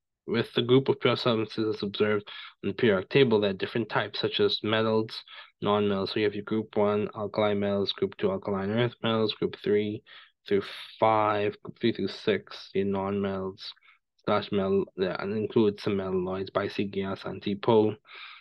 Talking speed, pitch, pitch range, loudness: 180 wpm, 105 Hz, 100-110 Hz, -28 LUFS